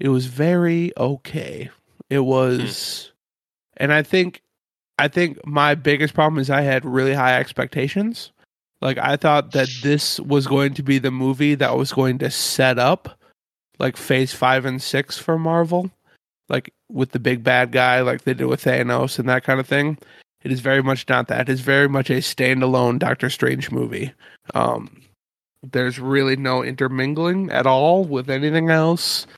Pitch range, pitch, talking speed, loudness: 130-150 Hz, 135 Hz, 175 wpm, -19 LUFS